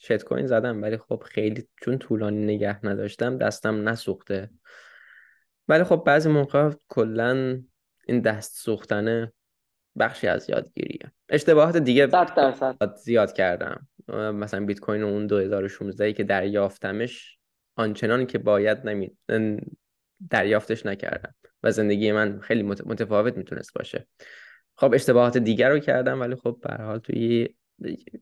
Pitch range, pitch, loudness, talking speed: 105-120 Hz, 110 Hz, -24 LUFS, 125 wpm